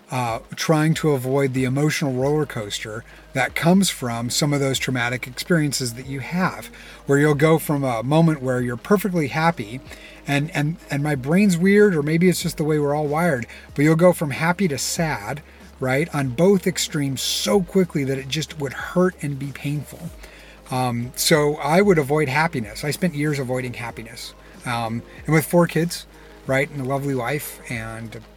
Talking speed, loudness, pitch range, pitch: 185 wpm, -21 LUFS, 130-160 Hz, 145 Hz